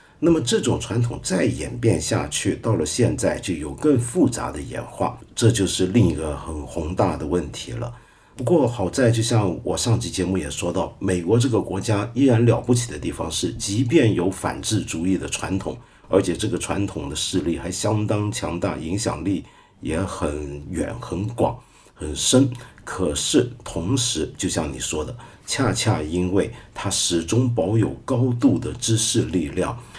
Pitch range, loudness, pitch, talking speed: 90-120 Hz, -22 LUFS, 100 Hz, 250 characters per minute